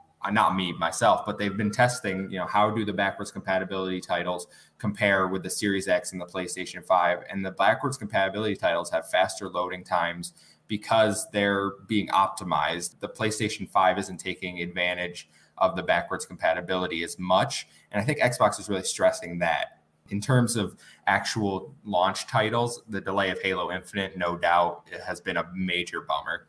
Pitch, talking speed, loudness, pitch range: 95 Hz, 170 wpm, -27 LUFS, 90-105 Hz